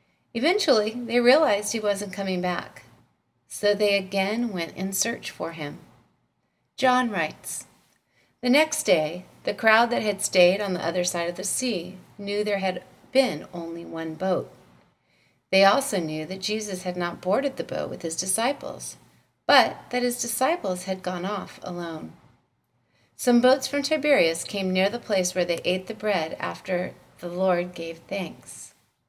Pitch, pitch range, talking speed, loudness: 195 Hz, 180-235 Hz, 160 wpm, -25 LUFS